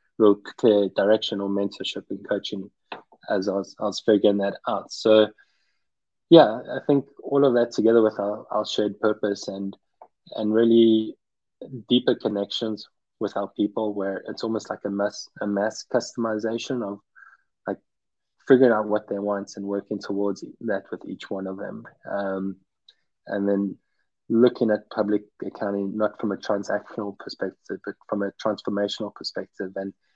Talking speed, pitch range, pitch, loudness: 155 wpm, 100-110 Hz, 105 Hz, -24 LUFS